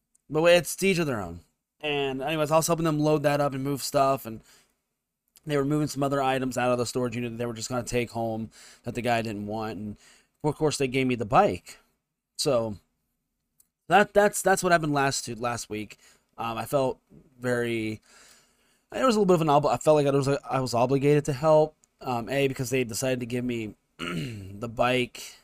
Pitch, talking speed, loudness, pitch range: 130 Hz, 215 wpm, -26 LUFS, 120-150 Hz